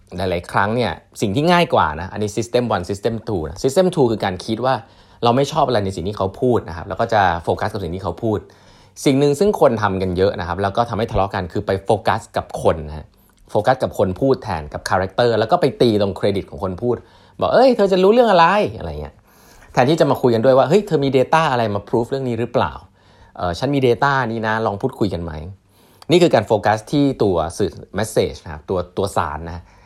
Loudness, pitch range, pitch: -18 LUFS, 95-130 Hz, 110 Hz